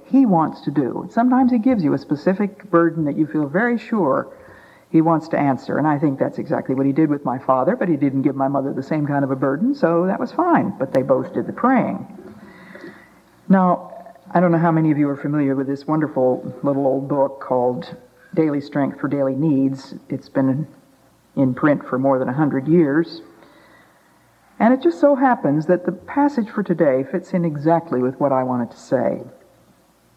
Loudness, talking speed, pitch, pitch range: -19 LUFS, 205 wpm, 155 Hz, 135-180 Hz